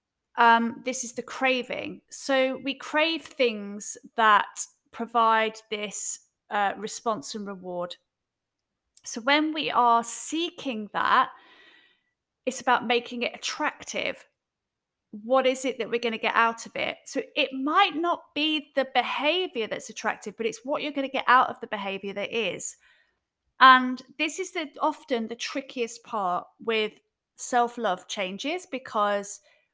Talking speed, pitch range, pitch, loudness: 145 wpm, 225-280 Hz, 245 Hz, -26 LUFS